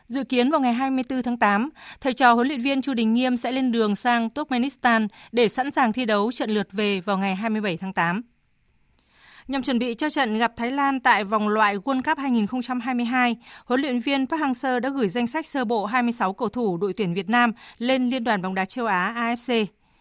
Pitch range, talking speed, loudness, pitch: 215-260 Hz, 220 wpm, -23 LUFS, 240 Hz